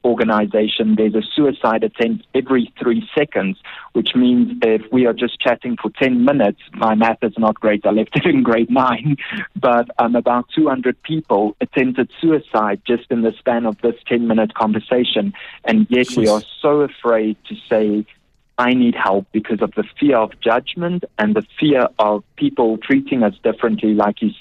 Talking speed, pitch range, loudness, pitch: 180 wpm, 110-140 Hz, -17 LUFS, 120 Hz